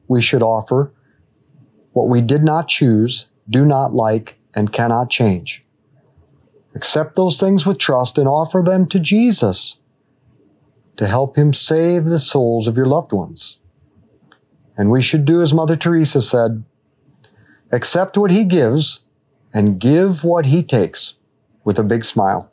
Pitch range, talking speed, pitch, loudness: 115-160 Hz, 145 wpm, 135 Hz, -15 LUFS